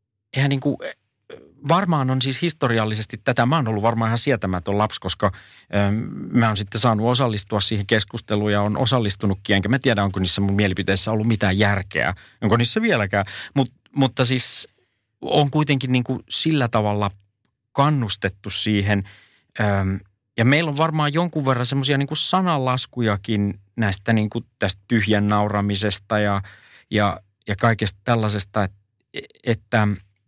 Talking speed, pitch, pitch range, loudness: 145 wpm, 110 Hz, 100-130 Hz, -21 LUFS